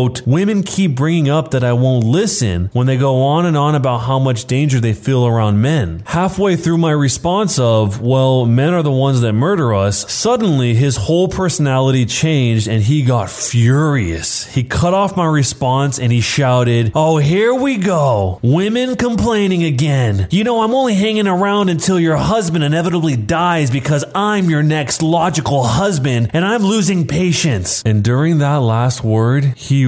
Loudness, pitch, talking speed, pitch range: -14 LUFS, 145 Hz, 175 wpm, 125-175 Hz